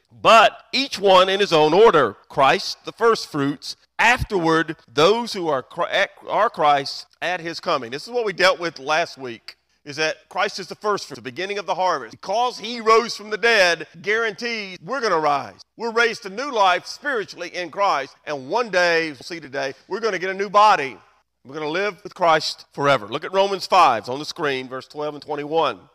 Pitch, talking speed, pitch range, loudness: 180 Hz, 210 wpm, 150-210 Hz, -20 LUFS